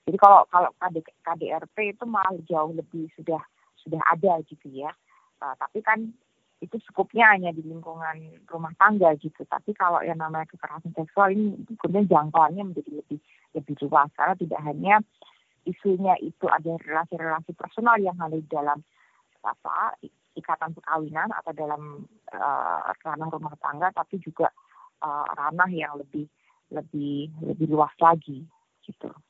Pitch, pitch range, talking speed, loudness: 165 Hz, 155-190 Hz, 145 wpm, -24 LUFS